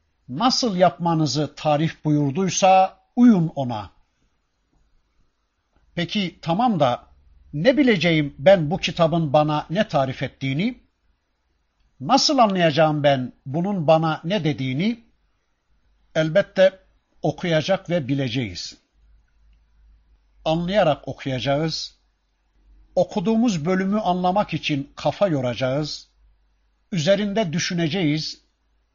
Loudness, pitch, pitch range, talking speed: -21 LUFS, 160 Hz, 135-190 Hz, 80 wpm